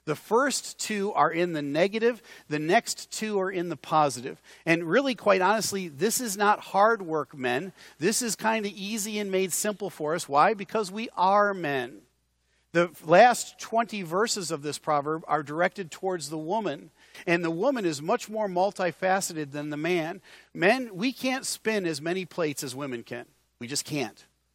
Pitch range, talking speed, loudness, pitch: 155-210 Hz, 180 wpm, -27 LUFS, 185 Hz